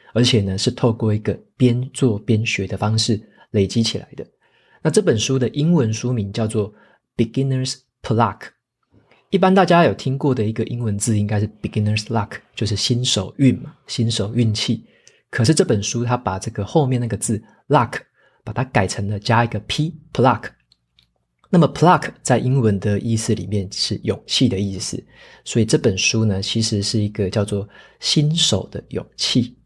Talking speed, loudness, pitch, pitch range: 315 characters per minute, -19 LUFS, 115 Hz, 105-125 Hz